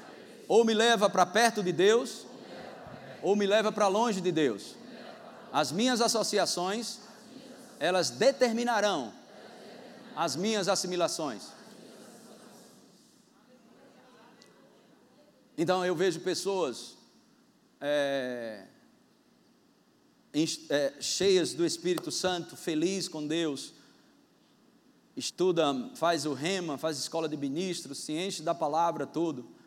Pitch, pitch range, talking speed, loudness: 190 Hz, 165-230 Hz, 95 wpm, -29 LUFS